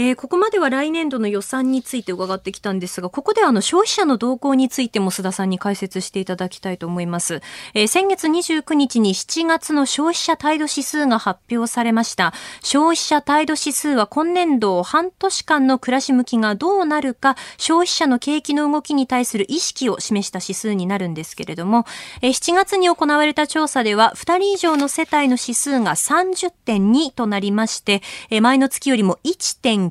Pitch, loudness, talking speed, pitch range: 260 Hz, -18 LUFS, 350 characters per minute, 205-310 Hz